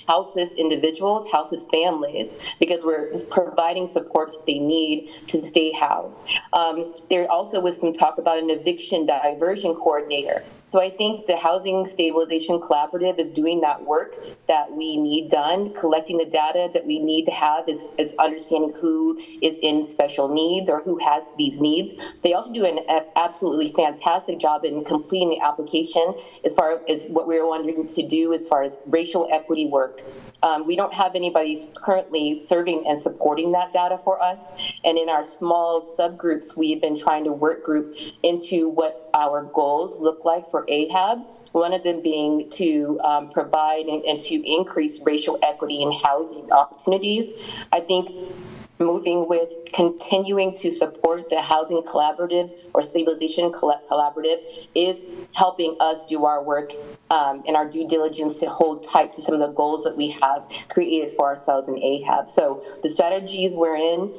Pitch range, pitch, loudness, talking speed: 155-180 Hz, 165 Hz, -22 LUFS, 165 wpm